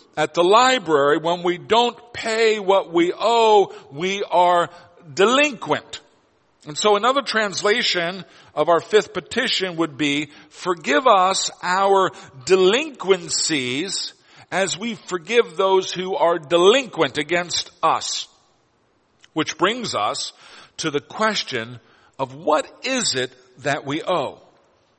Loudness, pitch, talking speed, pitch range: -20 LUFS, 185 Hz, 120 wpm, 160-210 Hz